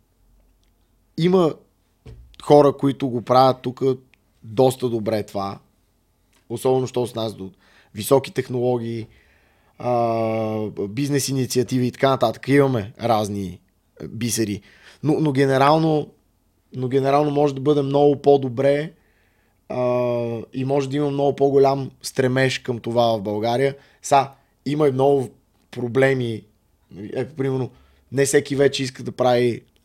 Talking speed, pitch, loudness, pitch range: 115 wpm, 125 Hz, -20 LUFS, 110-140 Hz